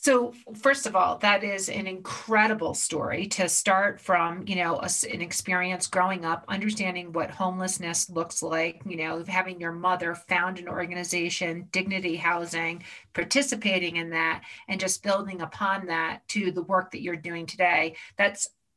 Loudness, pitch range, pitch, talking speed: -27 LUFS, 170-195 Hz, 180 Hz, 160 wpm